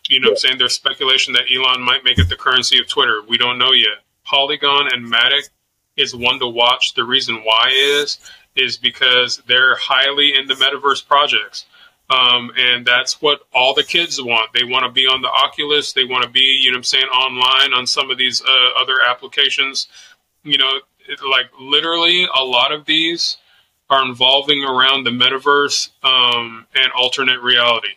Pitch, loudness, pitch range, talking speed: 130 Hz, -13 LUFS, 125-140 Hz, 190 wpm